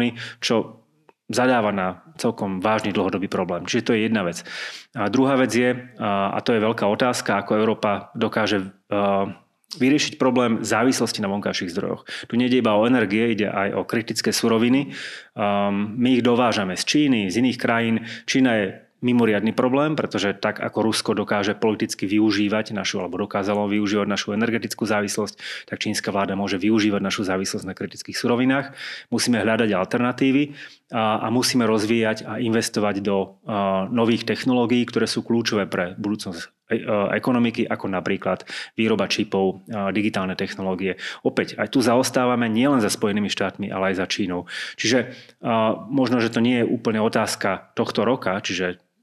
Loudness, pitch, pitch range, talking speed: -22 LUFS, 110 Hz, 100-120 Hz, 150 wpm